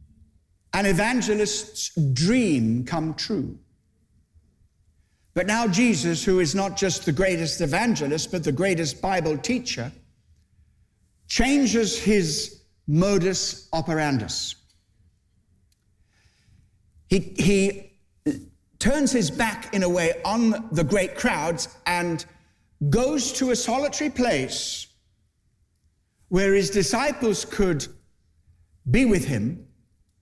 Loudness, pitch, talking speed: -23 LUFS, 165 Hz, 95 wpm